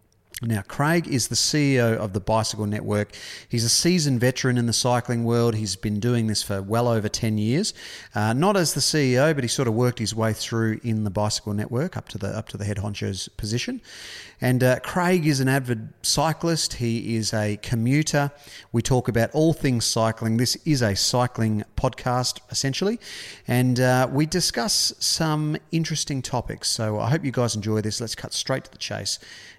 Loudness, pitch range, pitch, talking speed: -23 LUFS, 110-140 Hz, 120 Hz, 195 wpm